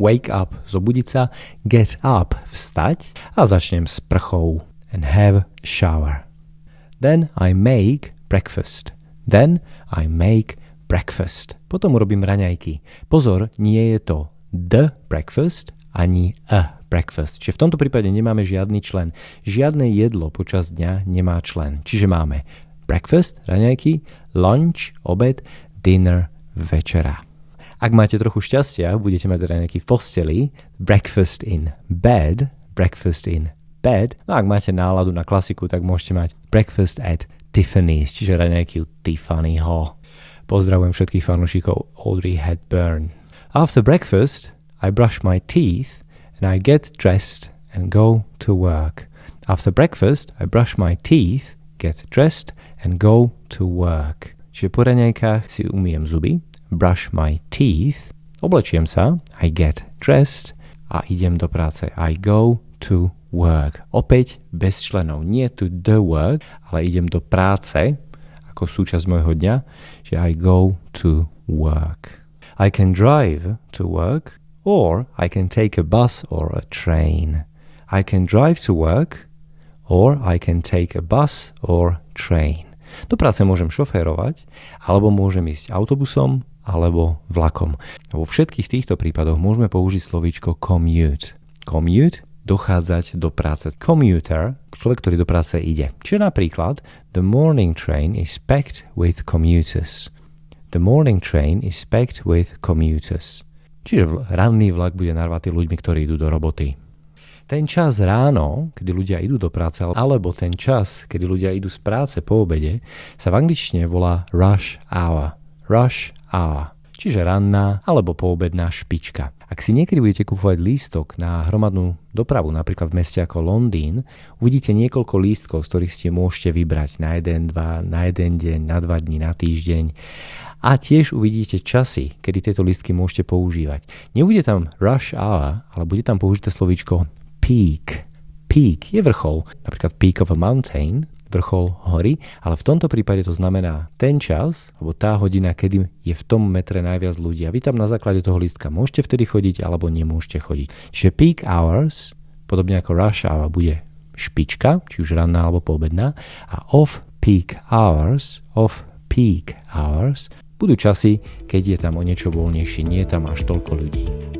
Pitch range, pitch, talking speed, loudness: 80-110 Hz, 90 Hz, 145 wpm, -18 LUFS